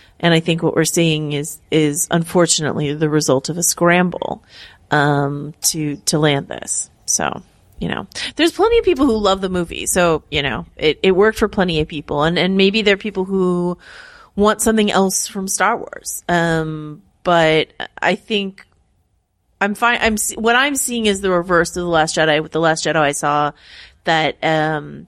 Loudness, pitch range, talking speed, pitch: -17 LUFS, 155-200 Hz, 185 wpm, 170 Hz